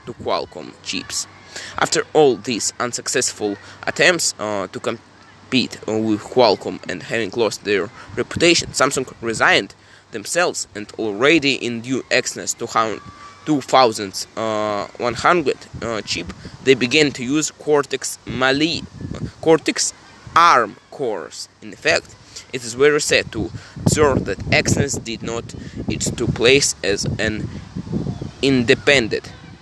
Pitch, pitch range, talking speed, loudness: 125 Hz, 105-140 Hz, 120 wpm, -19 LUFS